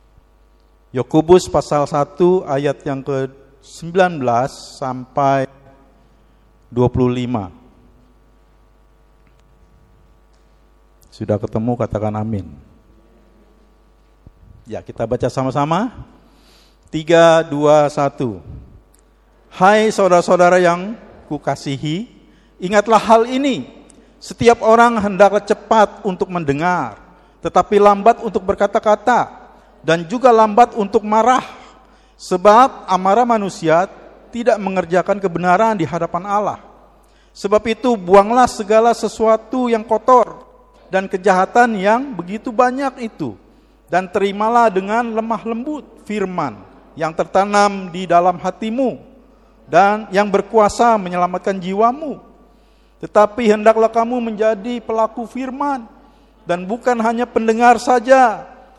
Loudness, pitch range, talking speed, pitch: -16 LUFS, 160-230 Hz, 90 wpm, 200 Hz